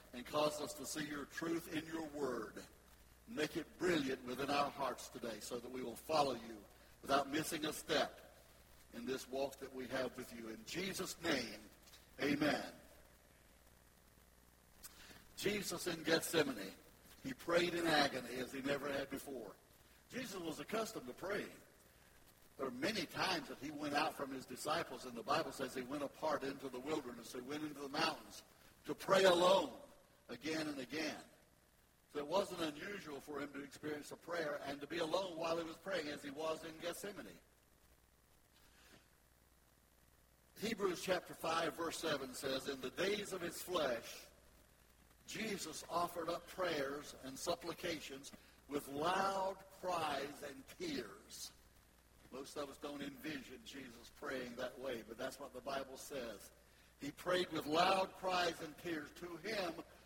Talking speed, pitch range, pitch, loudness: 160 wpm, 125-170 Hz, 145 Hz, -42 LUFS